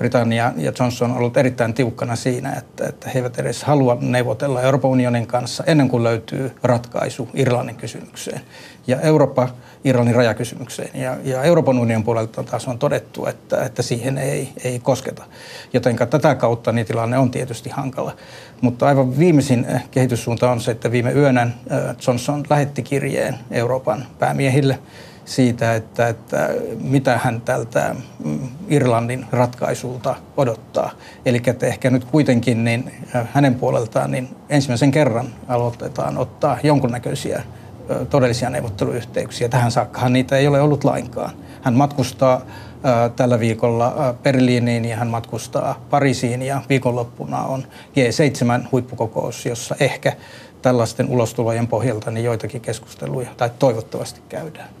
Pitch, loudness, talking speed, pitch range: 125 Hz, -19 LUFS, 130 wpm, 120-135 Hz